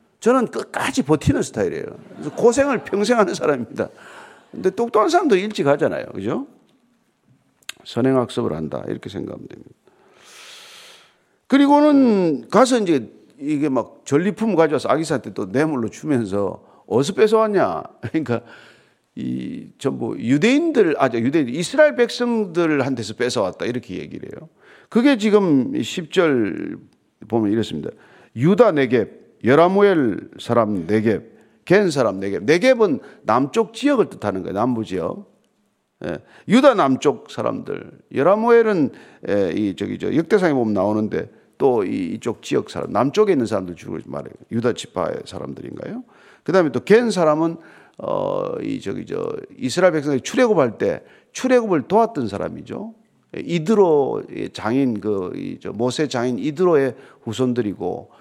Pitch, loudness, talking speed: 210 Hz, -19 LUFS, 305 characters per minute